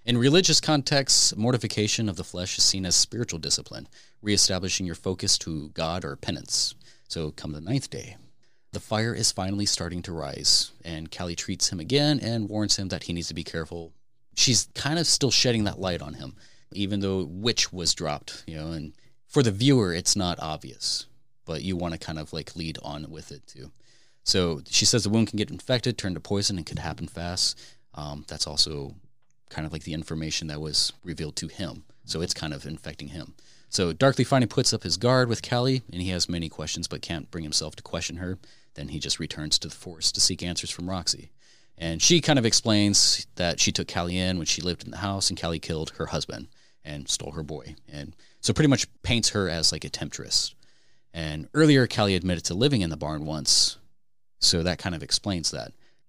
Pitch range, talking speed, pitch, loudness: 80-110 Hz, 210 wpm, 90 Hz, -25 LUFS